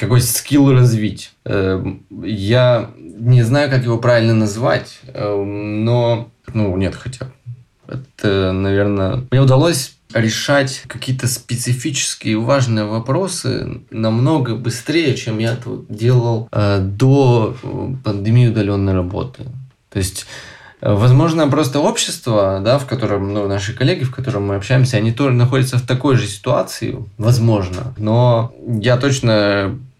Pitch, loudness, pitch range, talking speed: 120 Hz, -16 LUFS, 105-130 Hz, 120 wpm